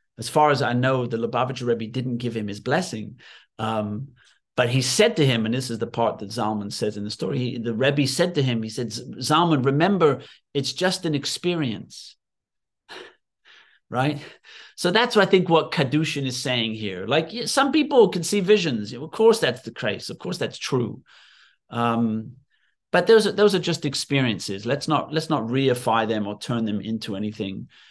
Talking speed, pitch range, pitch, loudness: 190 wpm, 115-160 Hz, 130 Hz, -23 LUFS